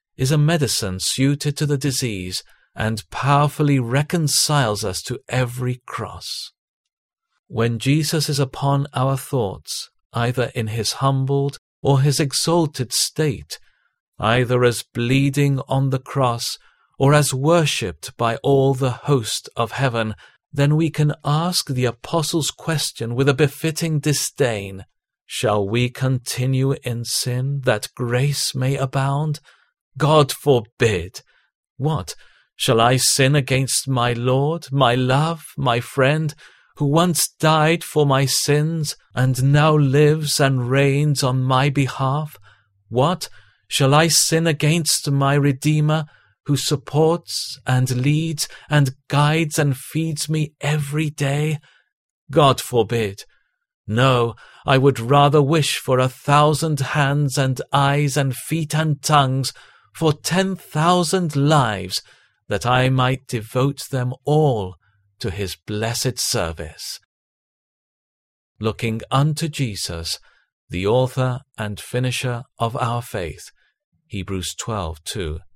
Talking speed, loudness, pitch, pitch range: 120 wpm, -20 LUFS, 135 Hz, 125-150 Hz